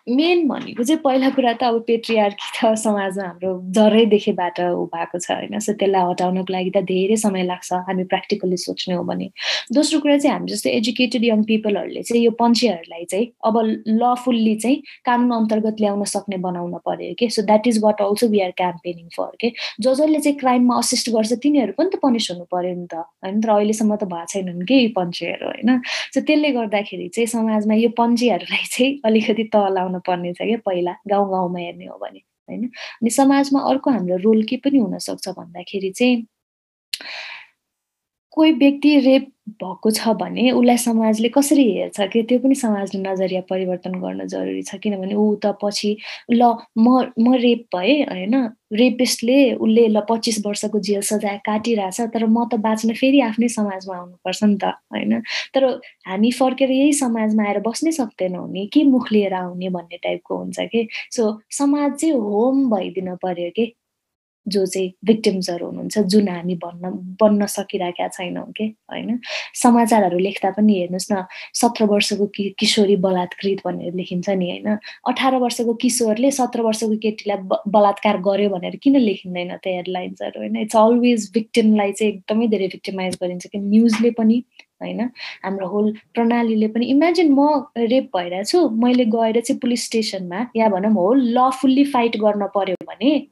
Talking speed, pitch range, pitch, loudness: 165 wpm, 190-240 Hz, 220 Hz, -19 LUFS